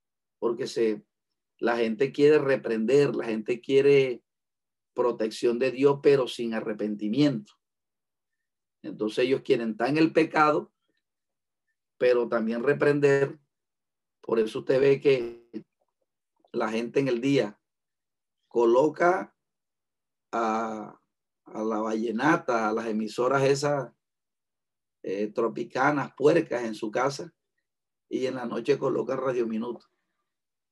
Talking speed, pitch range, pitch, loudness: 110 wpm, 115-145 Hz, 125 Hz, -26 LUFS